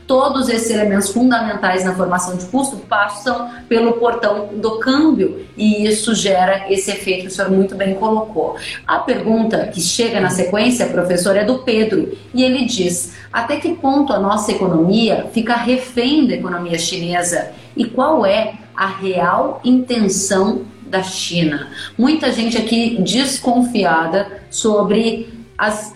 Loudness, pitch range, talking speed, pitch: -16 LUFS, 190-240 Hz, 145 wpm, 215 Hz